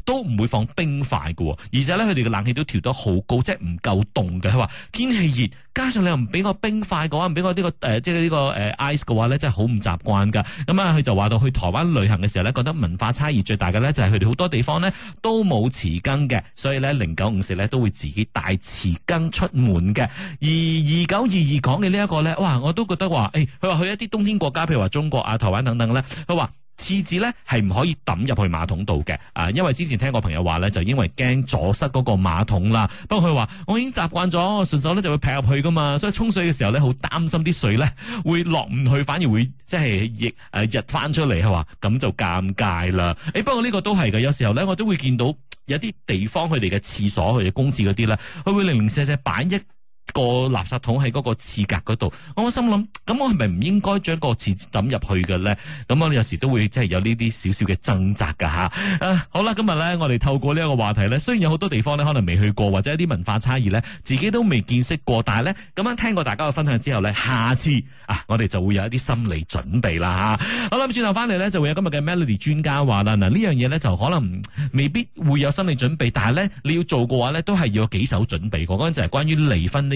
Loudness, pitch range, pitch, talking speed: -21 LUFS, 105-165 Hz, 130 Hz, 370 characters per minute